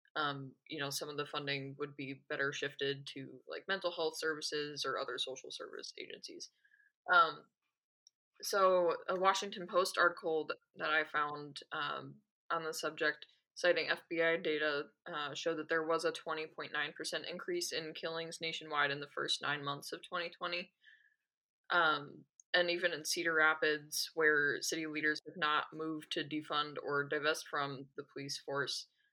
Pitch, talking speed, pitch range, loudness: 160 Hz, 155 wpm, 150-175 Hz, -36 LUFS